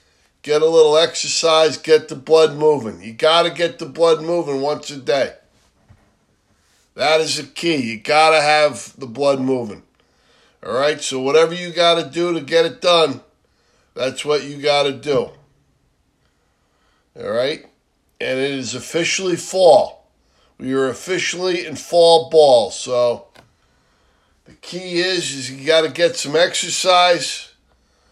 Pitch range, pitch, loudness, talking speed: 135-170 Hz, 155 Hz, -17 LUFS, 135 wpm